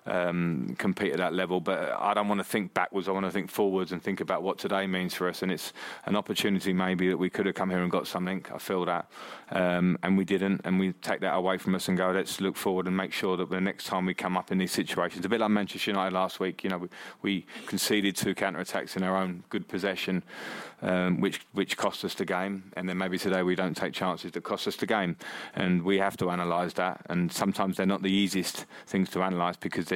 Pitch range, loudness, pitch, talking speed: 90-95 Hz, -29 LUFS, 95 Hz, 260 wpm